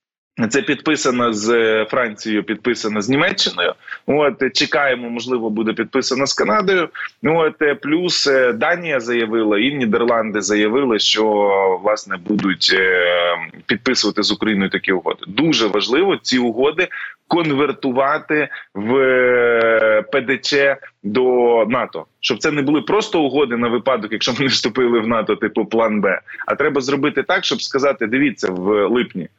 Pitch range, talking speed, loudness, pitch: 105-135 Hz, 130 wpm, -17 LUFS, 120 Hz